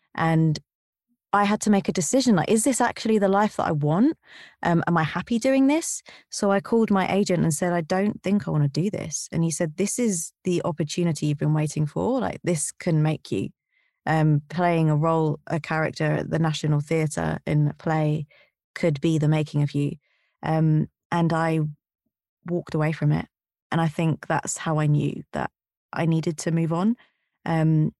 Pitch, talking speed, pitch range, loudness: 165 Hz, 200 wpm, 155-195 Hz, -24 LUFS